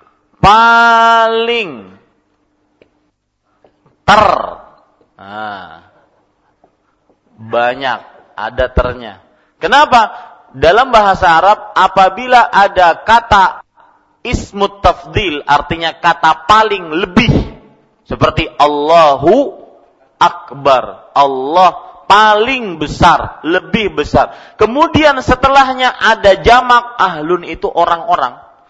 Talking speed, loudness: 70 wpm, -10 LUFS